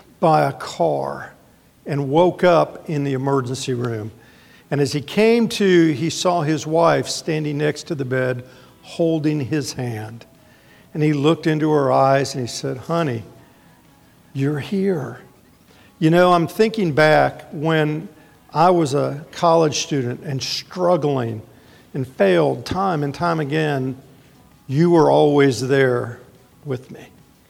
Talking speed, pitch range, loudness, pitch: 140 wpm, 135-165 Hz, -19 LUFS, 150 Hz